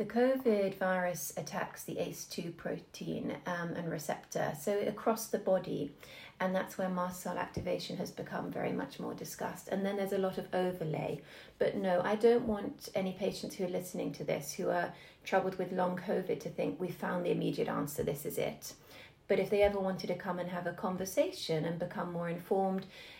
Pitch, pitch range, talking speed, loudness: 190 Hz, 180-200 Hz, 195 wpm, -35 LUFS